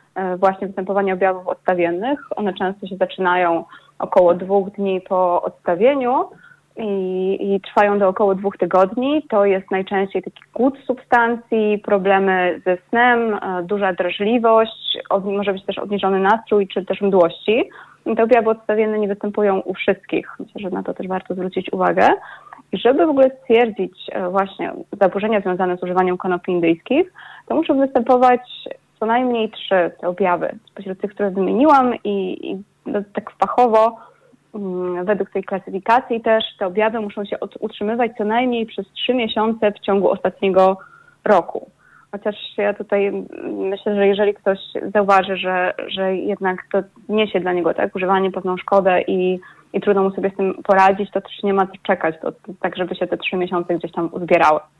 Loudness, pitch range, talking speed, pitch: -19 LUFS, 185-220 Hz, 160 wpm, 200 Hz